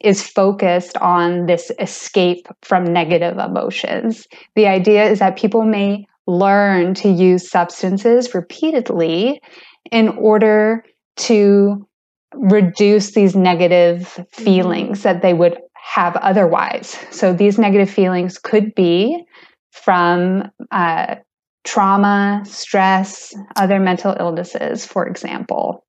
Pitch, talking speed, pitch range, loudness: 195 Hz, 105 wpm, 180-215 Hz, -15 LUFS